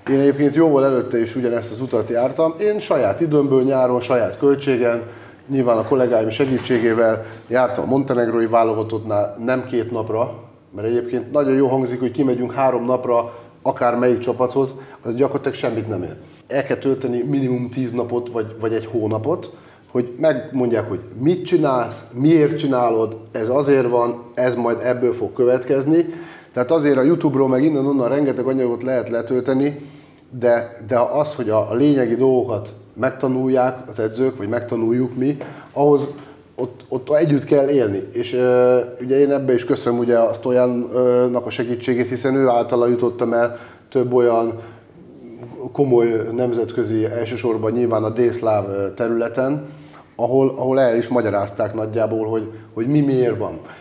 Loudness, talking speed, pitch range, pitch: -19 LUFS, 150 wpm, 115-135 Hz, 125 Hz